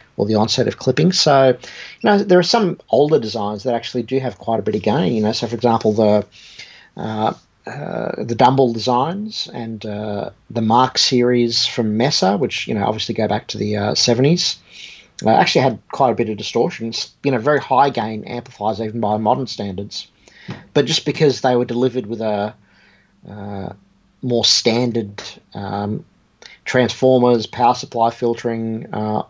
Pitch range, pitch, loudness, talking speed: 105-130 Hz, 115 Hz, -17 LUFS, 175 wpm